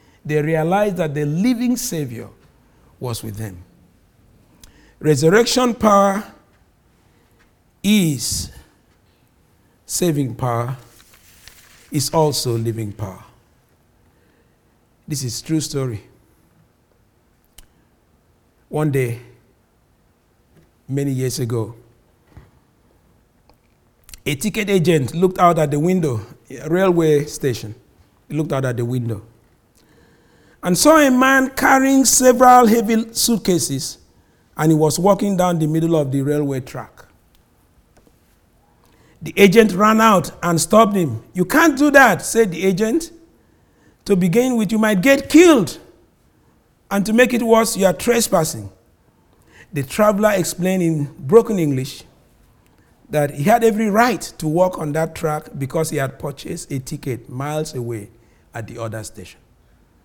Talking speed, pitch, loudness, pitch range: 120 wpm, 155 Hz, -17 LUFS, 125-205 Hz